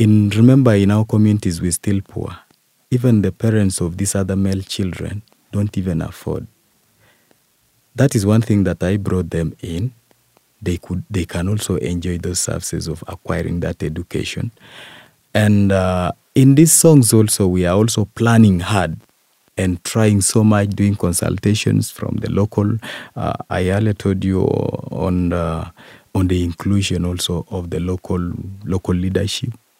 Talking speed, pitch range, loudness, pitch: 155 wpm, 90-110 Hz, -17 LUFS, 100 Hz